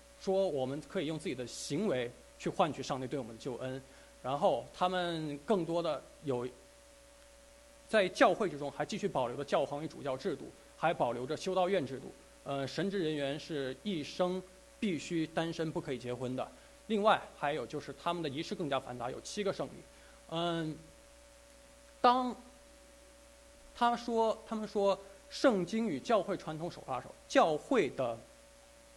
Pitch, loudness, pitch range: 185 Hz, -35 LUFS, 150-240 Hz